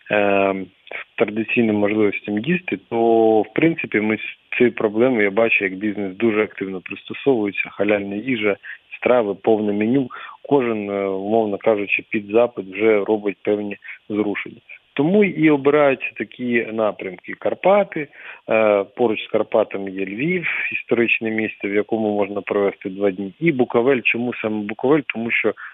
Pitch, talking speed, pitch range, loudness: 110 Hz, 135 wpm, 100-120 Hz, -20 LUFS